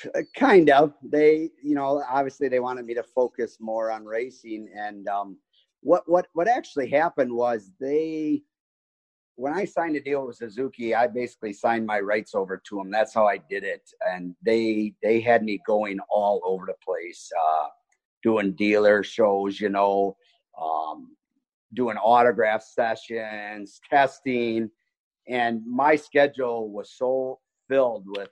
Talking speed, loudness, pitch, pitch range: 150 wpm, -24 LUFS, 120 Hz, 105-150 Hz